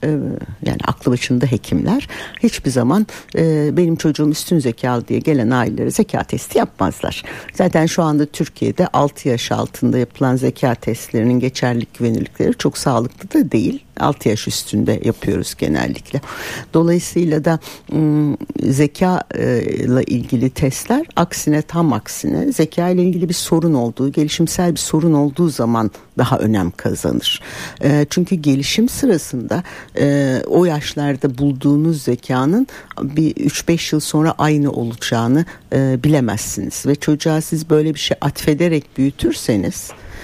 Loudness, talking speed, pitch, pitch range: -17 LUFS, 130 wpm, 145 Hz, 125-165 Hz